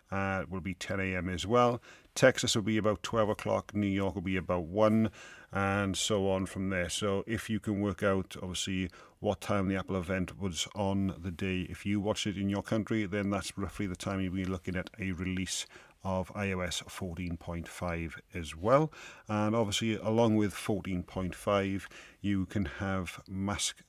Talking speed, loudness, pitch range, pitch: 180 wpm, -33 LUFS, 95-105 Hz, 95 Hz